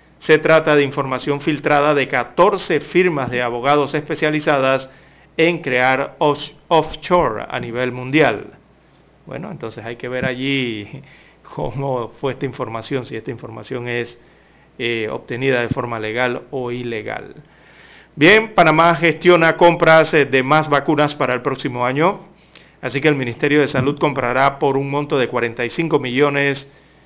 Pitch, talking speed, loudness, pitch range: 140 Hz, 140 wpm, -17 LUFS, 125-155 Hz